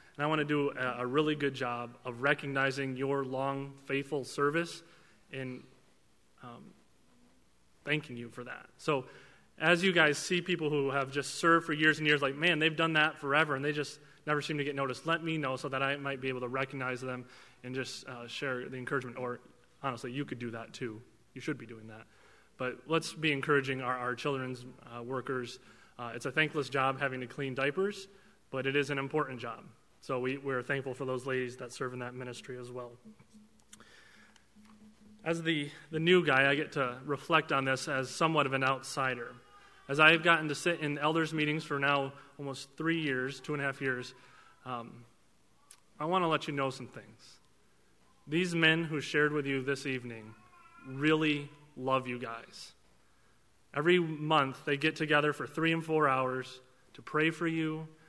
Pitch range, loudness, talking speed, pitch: 125-155 Hz, -32 LUFS, 190 wpm, 140 Hz